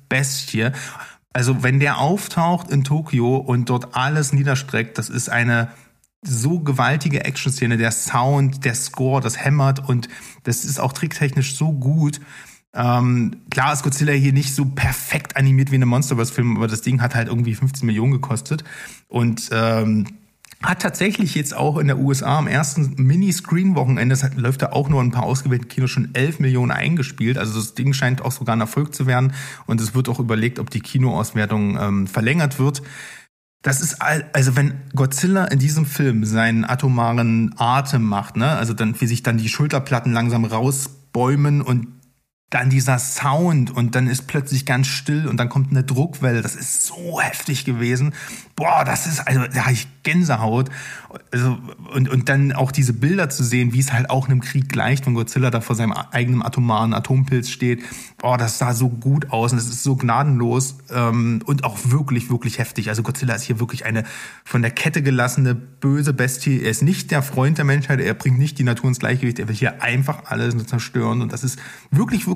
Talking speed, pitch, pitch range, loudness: 195 wpm, 130 Hz, 120-140 Hz, -19 LUFS